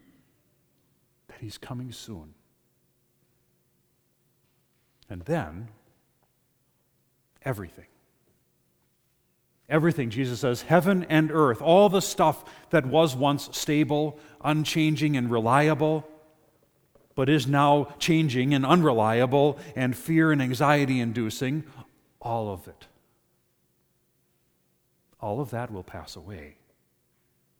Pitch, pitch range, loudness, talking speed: 140 Hz, 115-155 Hz, -24 LUFS, 90 wpm